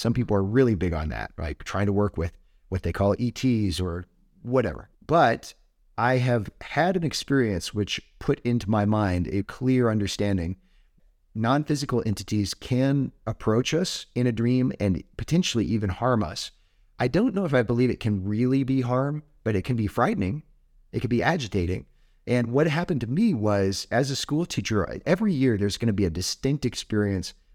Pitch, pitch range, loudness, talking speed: 110 Hz, 95-130 Hz, -25 LUFS, 185 wpm